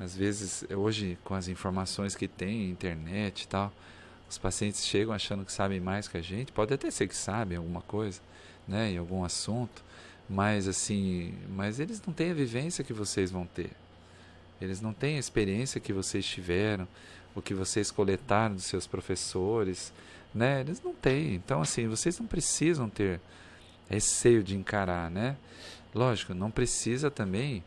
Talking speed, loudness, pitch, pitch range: 165 wpm, -32 LUFS, 100 Hz, 90-110 Hz